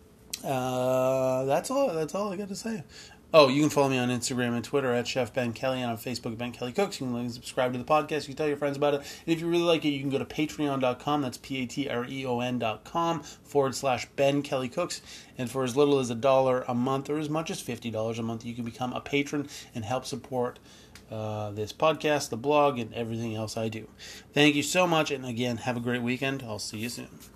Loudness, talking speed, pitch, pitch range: -28 LUFS, 245 wpm, 130 Hz, 120-145 Hz